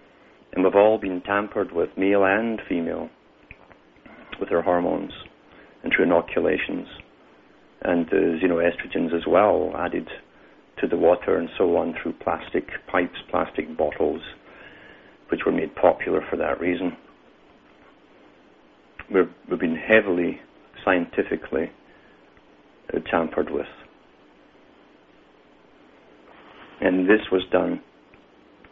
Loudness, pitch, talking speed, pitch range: -23 LUFS, 95 Hz, 110 wpm, 85-100 Hz